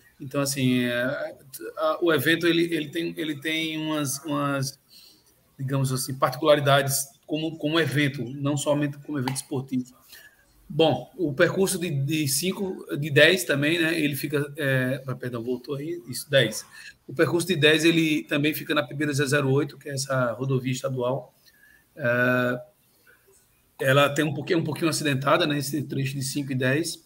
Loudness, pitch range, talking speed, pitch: -24 LUFS, 135-160 Hz, 155 wpm, 145 Hz